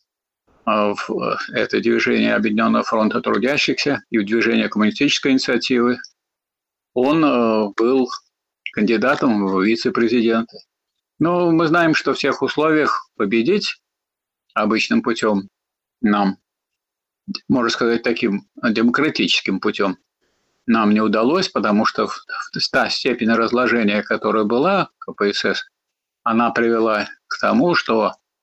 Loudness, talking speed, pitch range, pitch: -18 LUFS, 105 wpm, 110-130 Hz, 115 Hz